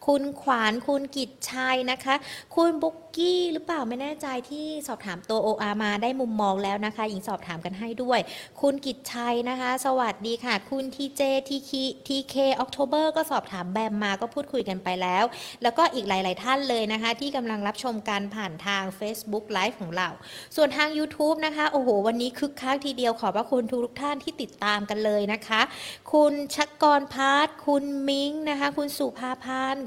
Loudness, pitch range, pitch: -27 LUFS, 215-285 Hz, 255 Hz